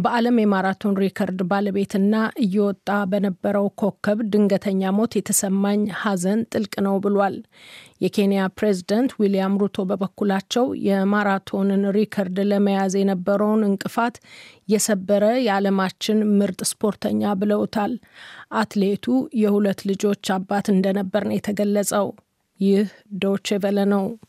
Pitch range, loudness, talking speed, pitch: 195-210 Hz, -21 LUFS, 100 wpm, 200 Hz